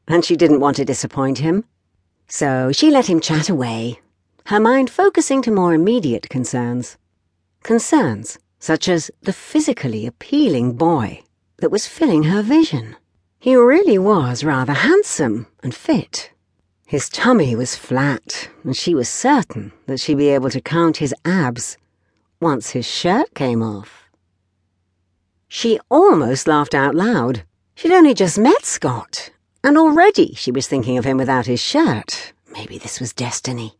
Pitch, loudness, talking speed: 145 Hz, -16 LUFS, 150 wpm